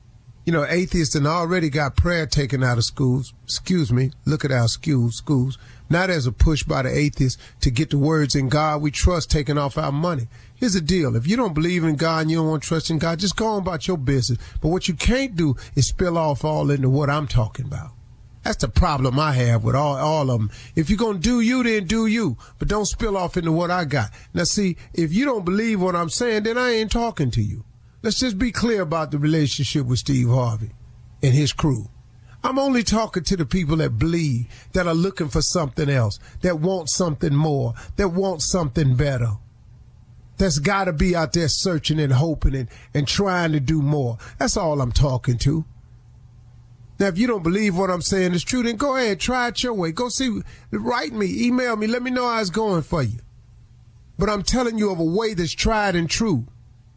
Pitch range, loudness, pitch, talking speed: 125-190 Hz, -21 LUFS, 155 Hz, 225 wpm